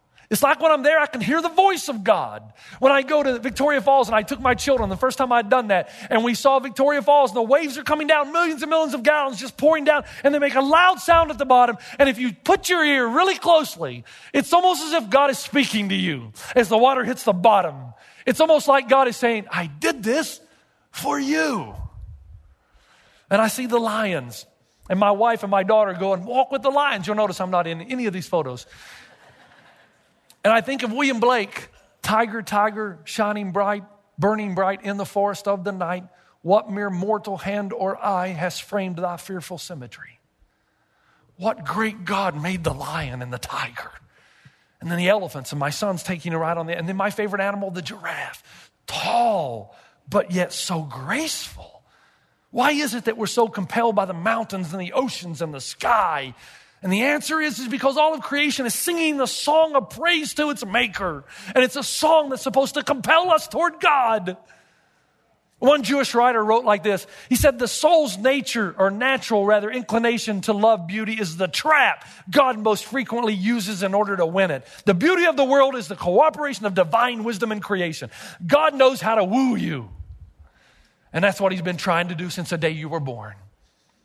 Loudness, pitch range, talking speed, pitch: -21 LUFS, 185-275 Hz, 205 wpm, 220 Hz